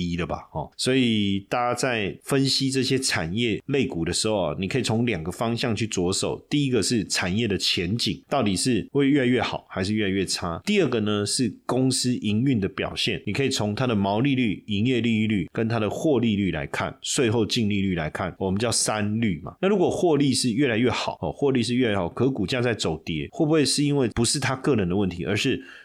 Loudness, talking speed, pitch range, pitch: -24 LUFS, 325 characters per minute, 100-130 Hz, 115 Hz